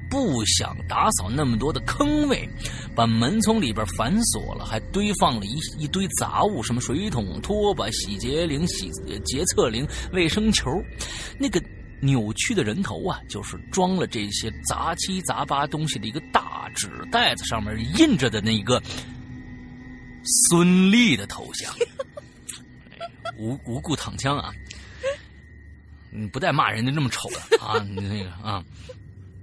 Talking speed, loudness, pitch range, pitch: 210 characters per minute, -23 LUFS, 105-175 Hz, 125 Hz